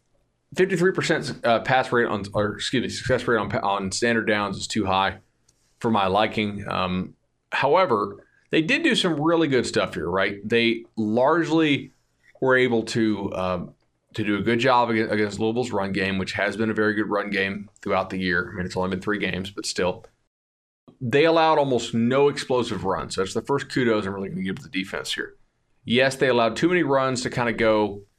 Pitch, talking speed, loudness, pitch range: 110 Hz, 205 wpm, -23 LUFS, 100-125 Hz